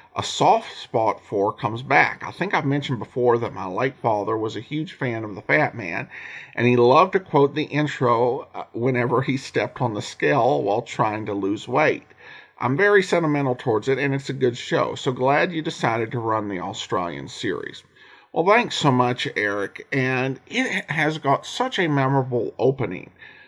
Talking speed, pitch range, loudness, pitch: 185 wpm, 120-150 Hz, -22 LUFS, 135 Hz